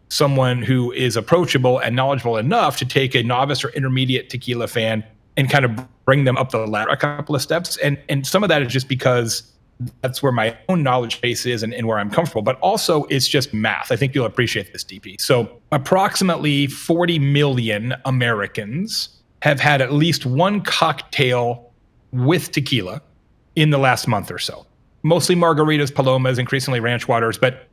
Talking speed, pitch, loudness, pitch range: 180 wpm, 130 Hz, -19 LUFS, 120-145 Hz